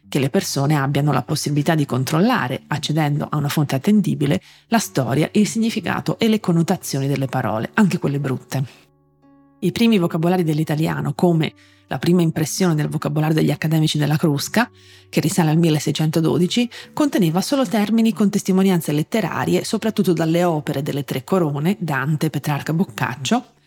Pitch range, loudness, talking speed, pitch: 145-185 Hz, -19 LUFS, 145 wpm, 160 Hz